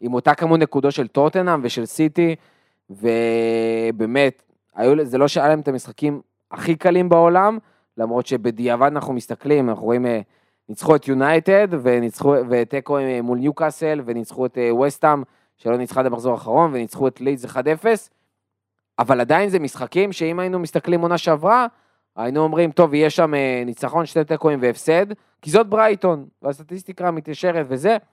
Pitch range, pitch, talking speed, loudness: 120-165 Hz, 145 Hz, 140 wpm, -19 LUFS